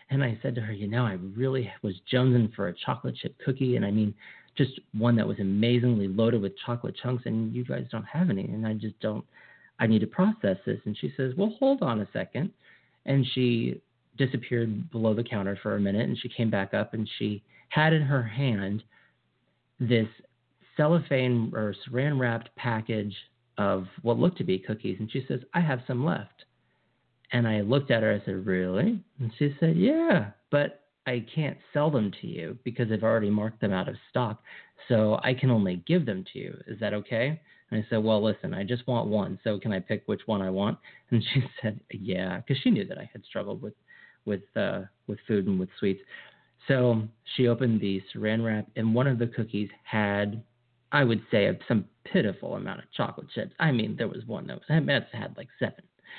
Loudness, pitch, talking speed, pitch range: -28 LUFS, 115 Hz, 210 wpm, 105-130 Hz